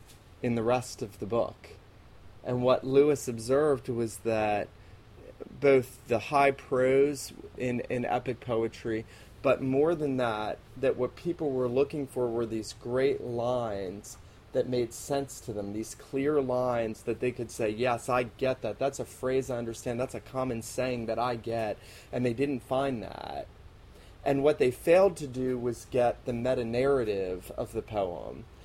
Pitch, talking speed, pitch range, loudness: 125 Hz, 170 wpm, 115-130 Hz, -30 LUFS